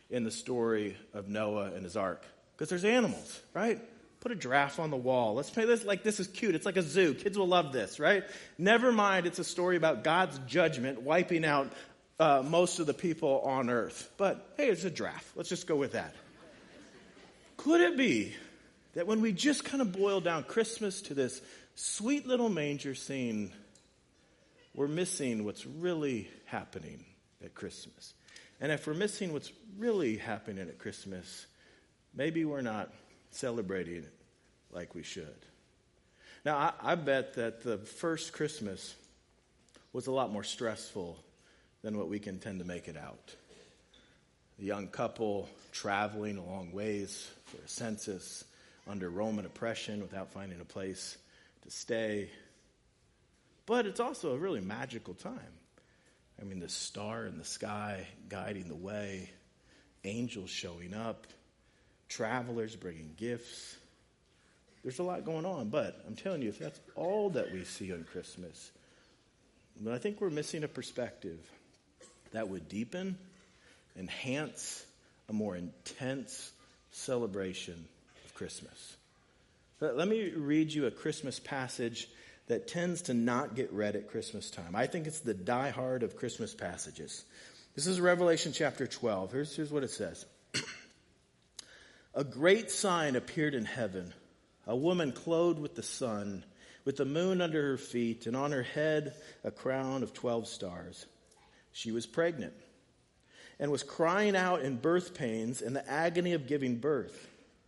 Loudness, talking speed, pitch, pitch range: -34 LUFS, 155 wpm, 135 Hz, 105-175 Hz